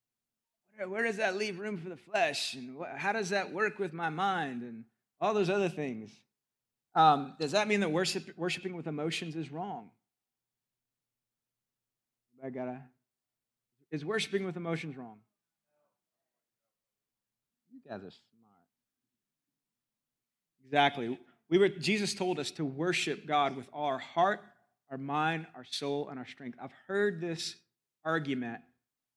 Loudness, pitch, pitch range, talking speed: -33 LUFS, 150 Hz, 125-190 Hz, 140 wpm